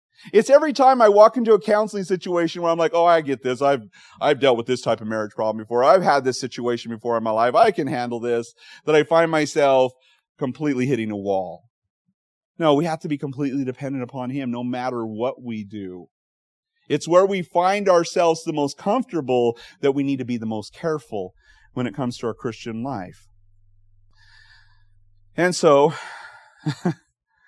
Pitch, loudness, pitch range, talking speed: 130 Hz, -21 LUFS, 115-165 Hz, 185 wpm